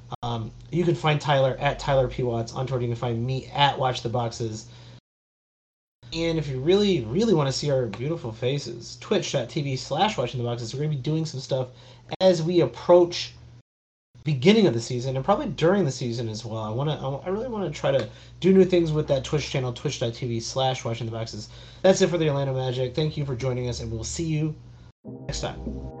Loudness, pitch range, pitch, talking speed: -25 LUFS, 120-155 Hz, 130 Hz, 205 wpm